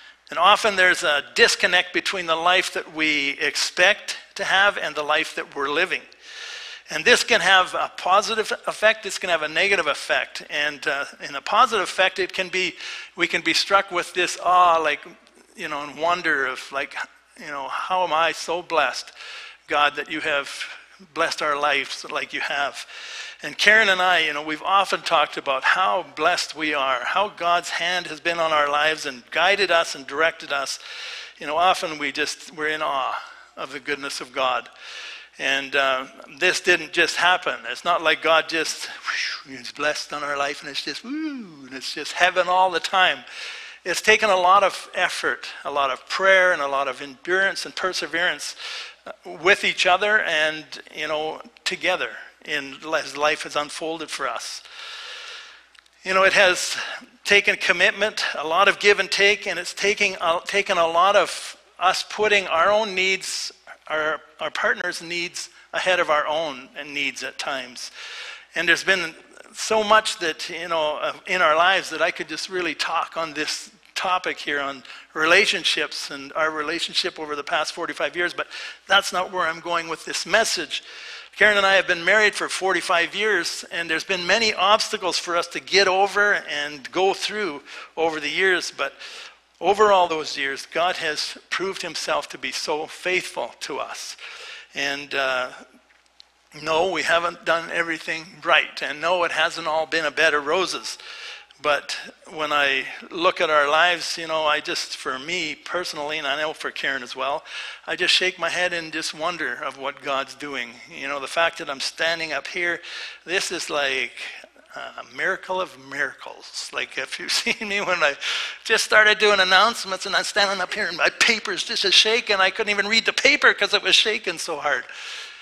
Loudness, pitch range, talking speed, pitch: -21 LUFS, 155-205 Hz, 190 wpm, 180 Hz